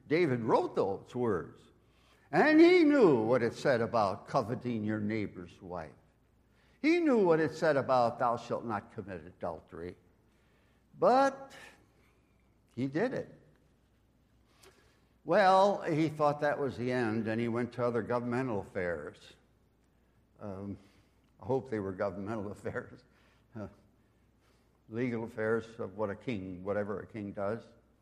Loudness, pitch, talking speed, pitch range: -31 LUFS, 115 Hz, 135 wpm, 105-130 Hz